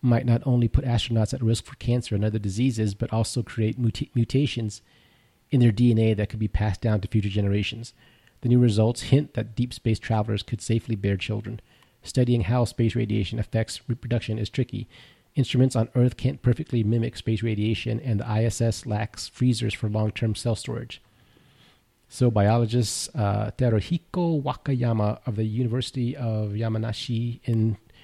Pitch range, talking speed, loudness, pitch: 110-125 Hz, 165 wpm, -25 LUFS, 115 Hz